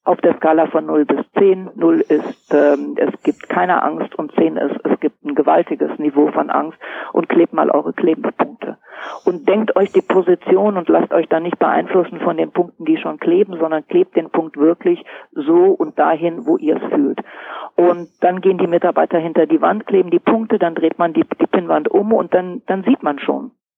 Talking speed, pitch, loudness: 205 wpm, 185 Hz, -16 LUFS